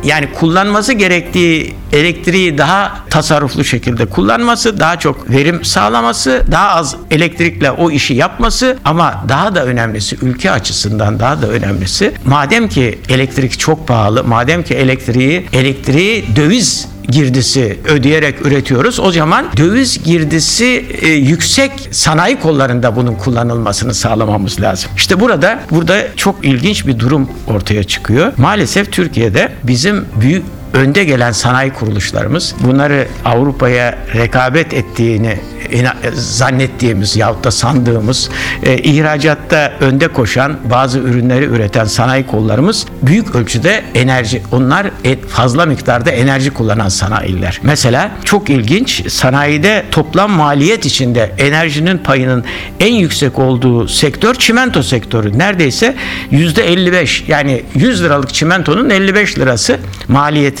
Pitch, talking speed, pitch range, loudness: 135 Hz, 115 wpm, 120-160 Hz, -11 LUFS